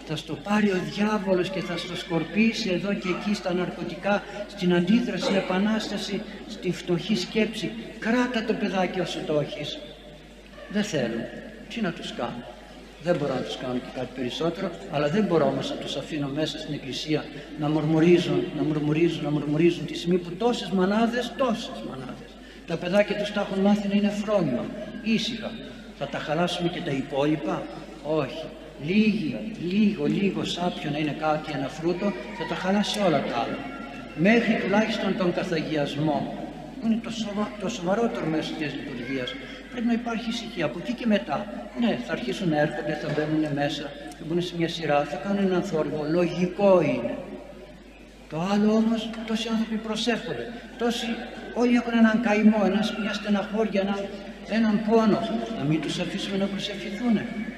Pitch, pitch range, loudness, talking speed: 195 Hz, 165-215 Hz, -26 LUFS, 165 wpm